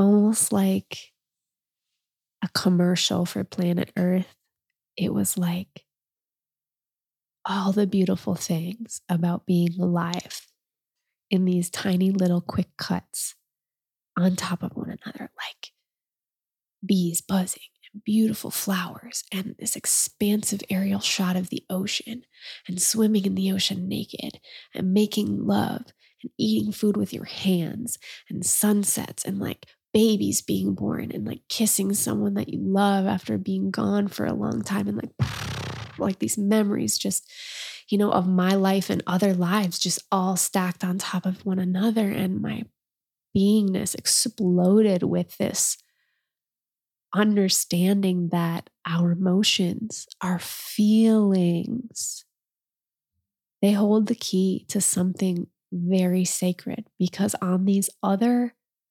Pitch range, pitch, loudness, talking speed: 180-210 Hz, 190 Hz, -24 LUFS, 125 wpm